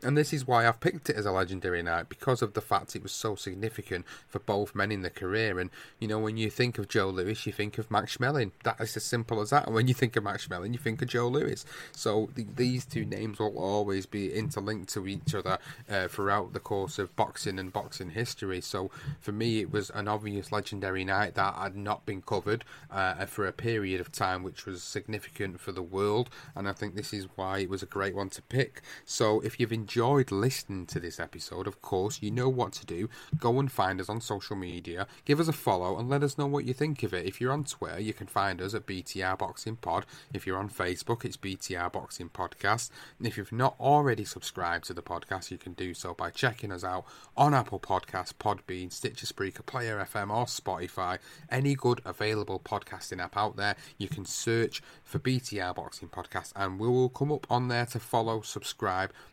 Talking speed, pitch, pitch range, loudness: 225 wpm, 105 Hz, 95-120 Hz, -32 LUFS